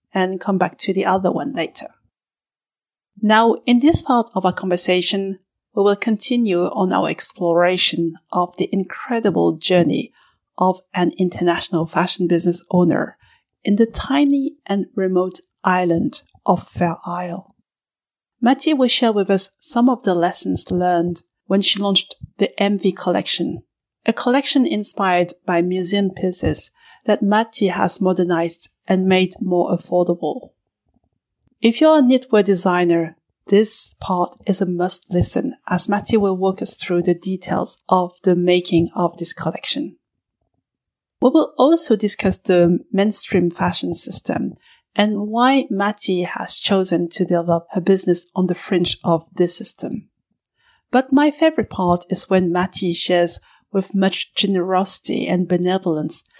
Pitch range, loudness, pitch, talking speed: 175-210 Hz, -19 LUFS, 185 Hz, 140 wpm